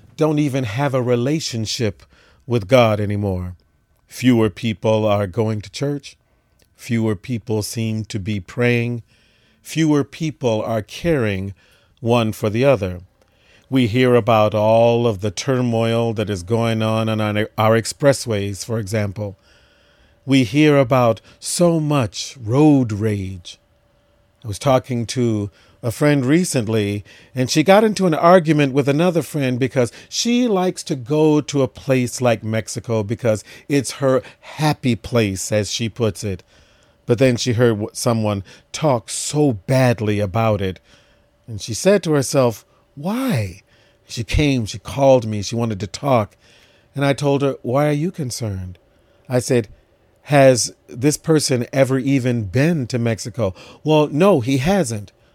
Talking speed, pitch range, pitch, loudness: 145 wpm, 110-135 Hz, 115 Hz, -18 LUFS